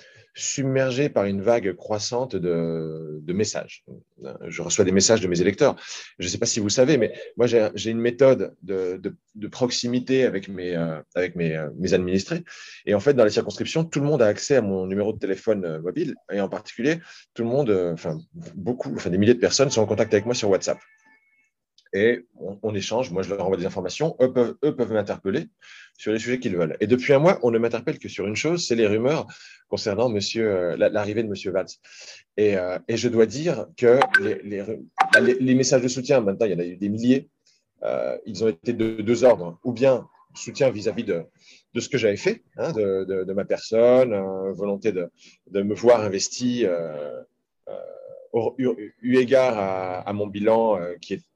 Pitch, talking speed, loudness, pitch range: 115 Hz, 210 wpm, -23 LUFS, 100-130 Hz